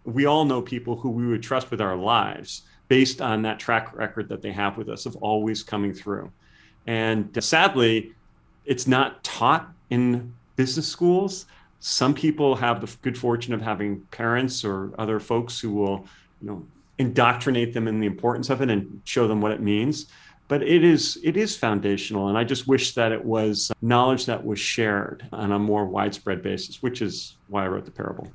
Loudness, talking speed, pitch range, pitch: -24 LUFS, 195 wpm, 105-130 Hz, 115 Hz